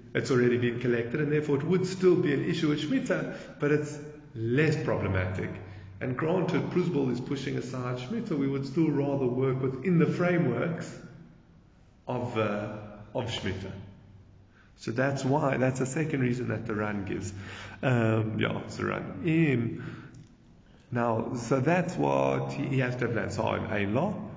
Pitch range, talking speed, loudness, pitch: 110-150 Hz, 165 wpm, -29 LUFS, 125 Hz